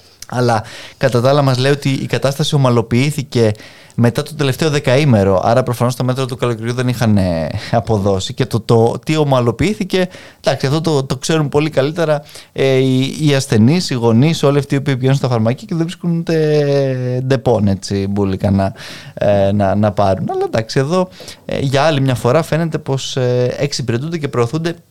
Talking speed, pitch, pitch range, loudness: 175 wpm, 130 Hz, 115-145 Hz, -15 LUFS